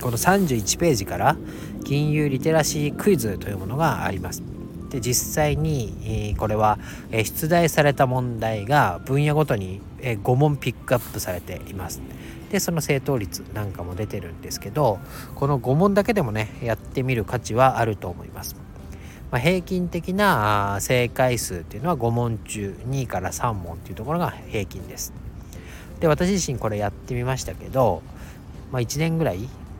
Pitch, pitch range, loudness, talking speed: 115 Hz, 95-145 Hz, -23 LUFS, 310 characters per minute